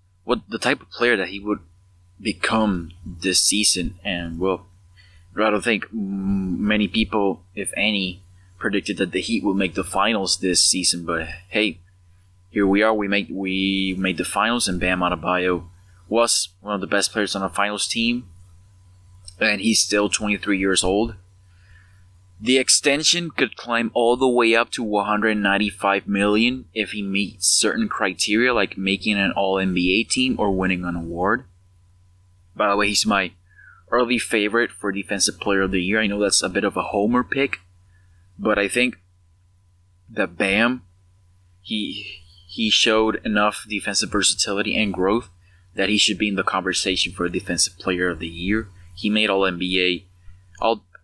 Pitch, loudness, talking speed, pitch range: 95 Hz, -21 LUFS, 160 wpm, 90-105 Hz